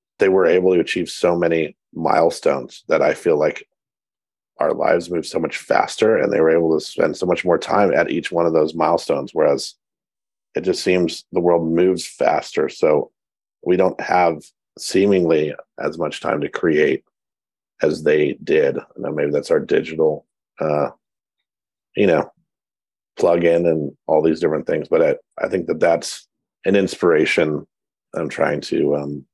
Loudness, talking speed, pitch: -19 LUFS, 170 wpm, 90 Hz